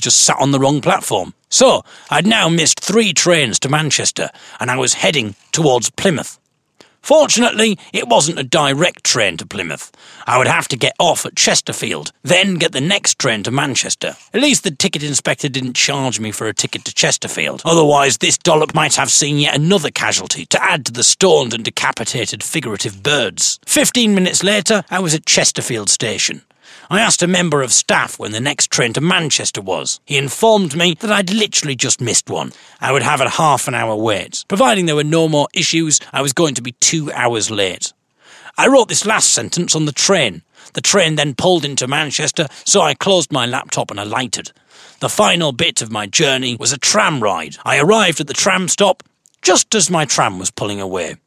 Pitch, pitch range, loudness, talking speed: 155 Hz, 135-190 Hz, -14 LUFS, 200 wpm